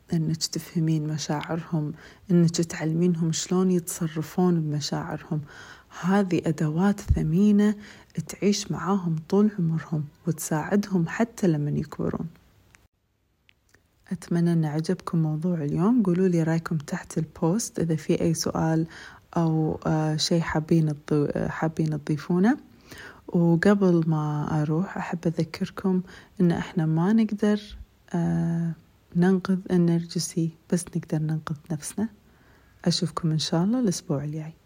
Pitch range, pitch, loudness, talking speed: 155-185 Hz, 170 Hz, -25 LUFS, 105 wpm